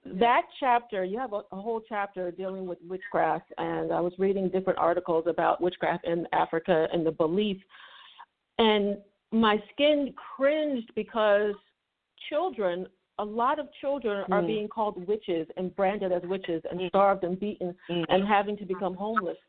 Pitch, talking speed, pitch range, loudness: 195 Hz, 155 wpm, 180-215 Hz, -28 LUFS